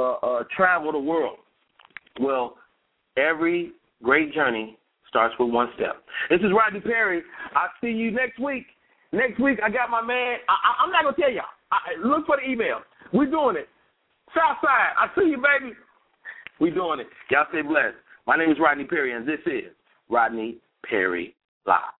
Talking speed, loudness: 185 wpm, -23 LUFS